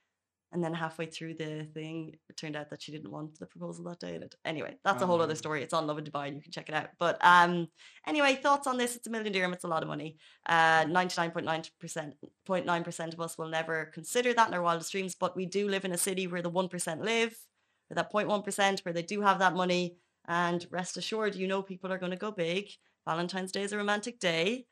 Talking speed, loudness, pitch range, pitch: 250 wpm, -31 LUFS, 160-195 Hz, 175 Hz